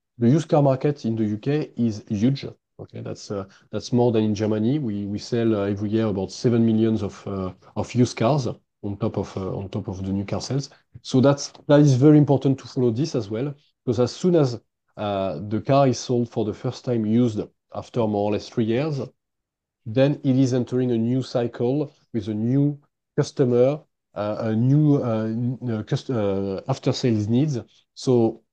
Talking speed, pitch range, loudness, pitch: 200 wpm, 110-135 Hz, -23 LUFS, 120 Hz